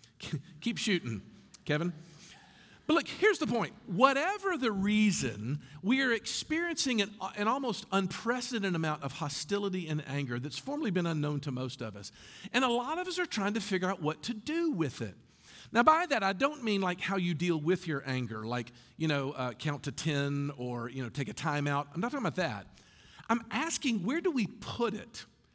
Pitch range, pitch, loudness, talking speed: 140-235 Hz, 180 Hz, -32 LUFS, 195 wpm